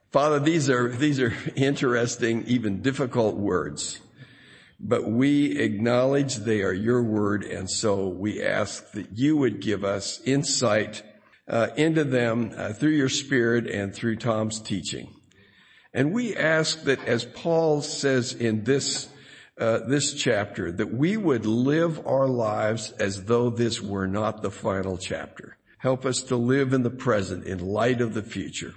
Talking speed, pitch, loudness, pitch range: 155 wpm, 120 Hz, -25 LUFS, 110-140 Hz